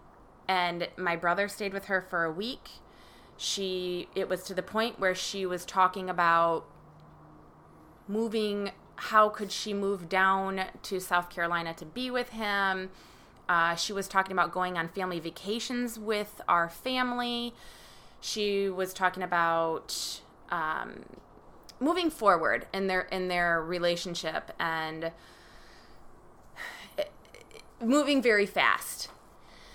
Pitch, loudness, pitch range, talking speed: 190 Hz, -30 LUFS, 175-210 Hz, 125 wpm